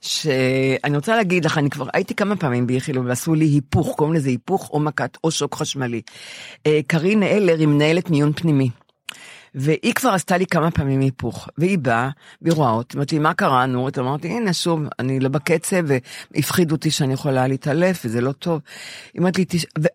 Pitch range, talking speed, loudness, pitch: 135-170 Hz, 175 wpm, -20 LUFS, 150 Hz